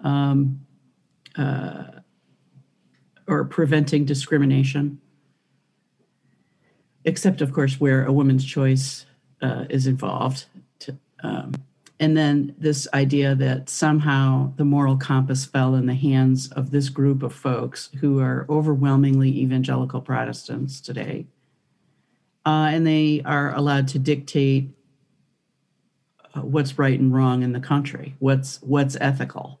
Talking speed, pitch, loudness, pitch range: 120 wpm, 140 Hz, -21 LUFS, 135-145 Hz